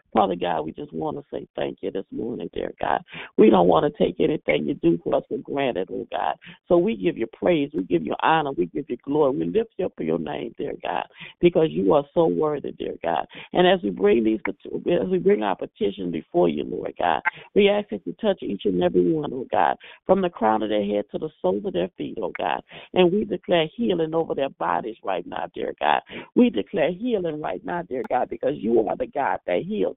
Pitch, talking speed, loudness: 165 Hz, 240 wpm, -24 LUFS